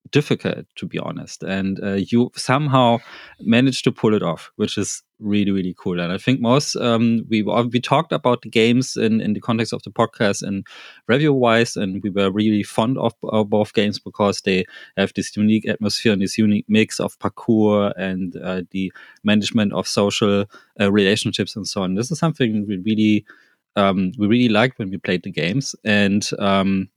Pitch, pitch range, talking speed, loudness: 105 Hz, 100-115 Hz, 195 wpm, -20 LUFS